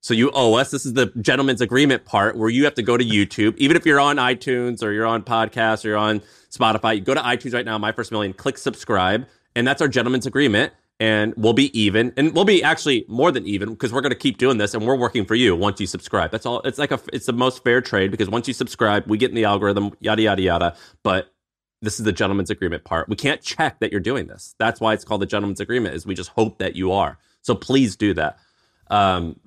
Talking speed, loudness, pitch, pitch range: 260 wpm, -20 LUFS, 115 Hz, 105-130 Hz